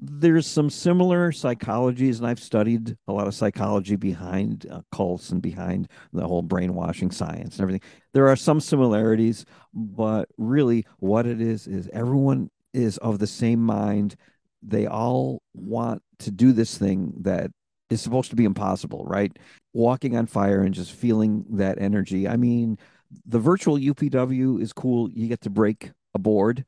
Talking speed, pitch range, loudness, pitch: 165 wpm, 100-125 Hz, -23 LUFS, 115 Hz